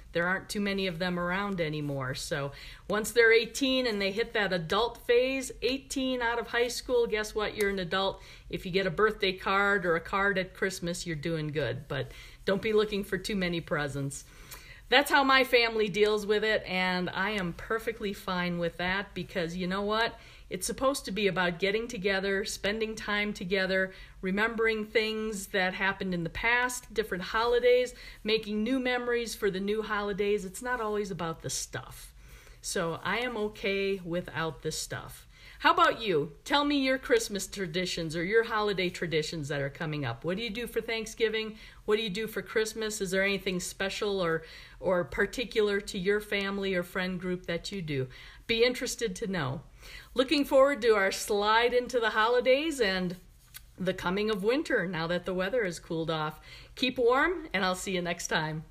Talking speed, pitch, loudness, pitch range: 185 wpm, 200 Hz, -29 LUFS, 180-225 Hz